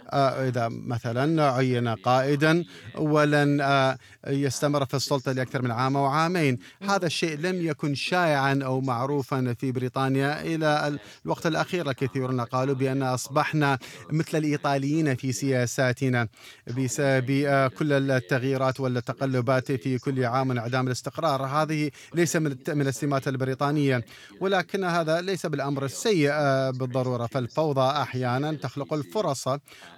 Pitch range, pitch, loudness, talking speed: 130-150 Hz, 135 Hz, -26 LUFS, 125 wpm